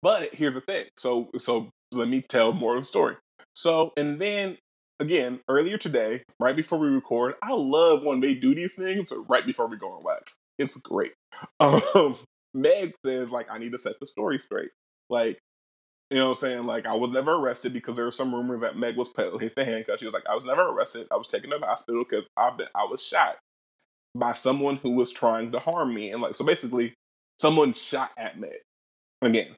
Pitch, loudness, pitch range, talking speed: 130 Hz, -26 LUFS, 125-195 Hz, 215 wpm